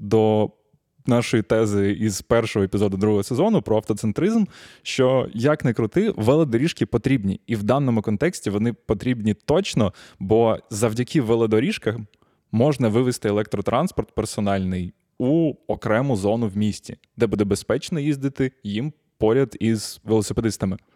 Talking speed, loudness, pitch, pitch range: 125 wpm, -22 LUFS, 115 Hz, 105-135 Hz